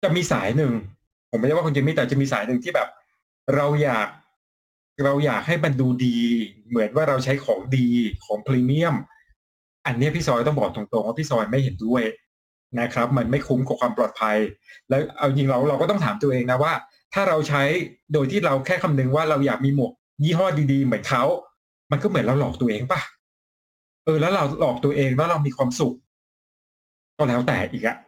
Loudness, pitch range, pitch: -22 LUFS, 120-150 Hz, 135 Hz